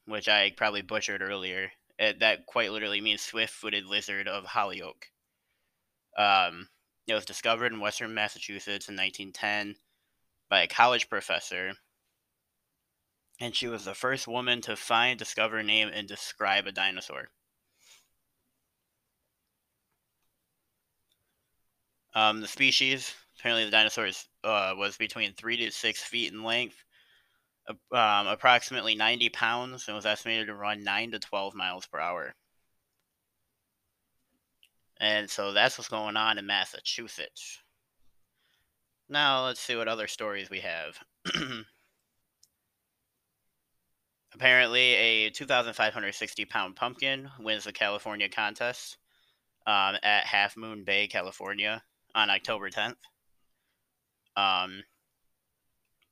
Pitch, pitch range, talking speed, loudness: 110 Hz, 105-120 Hz, 115 wpm, -28 LUFS